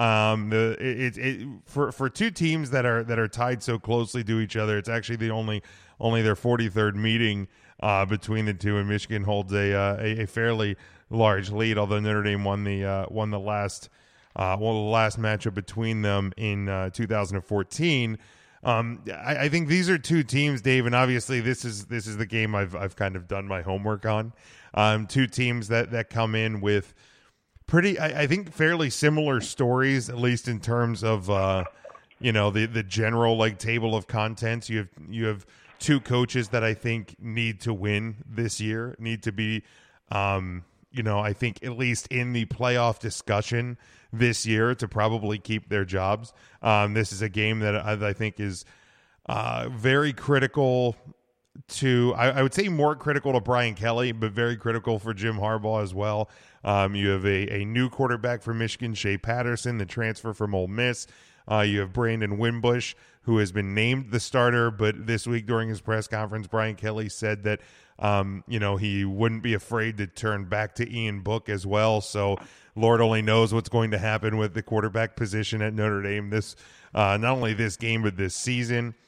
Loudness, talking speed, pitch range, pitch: -26 LUFS, 195 wpm, 105-120 Hz, 110 Hz